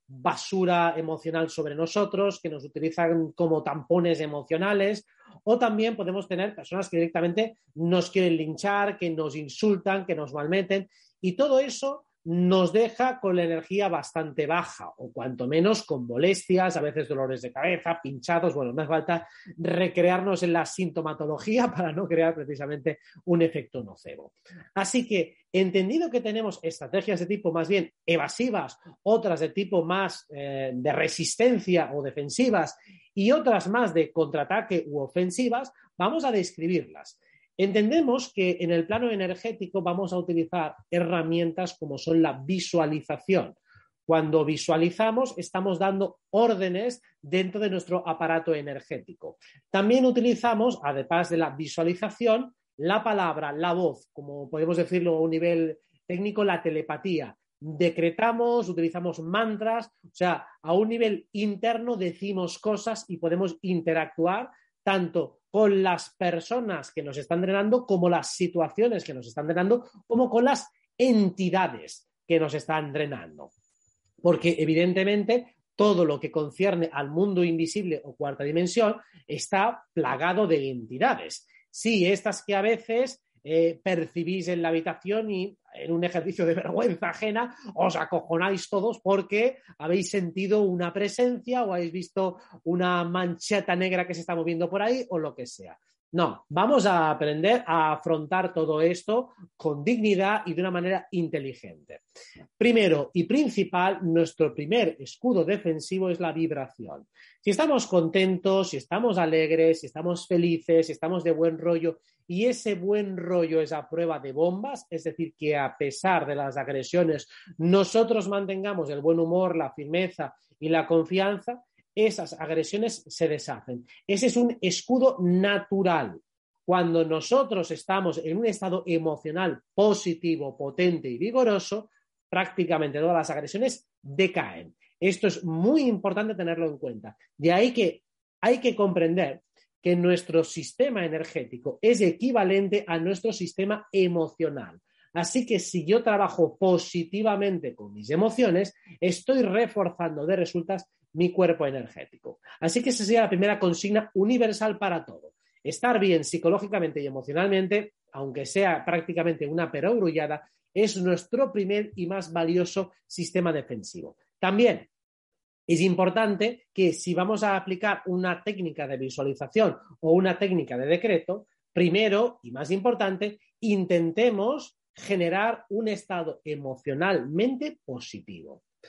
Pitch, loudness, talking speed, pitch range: 180 Hz, -26 LUFS, 140 wpm, 165-205 Hz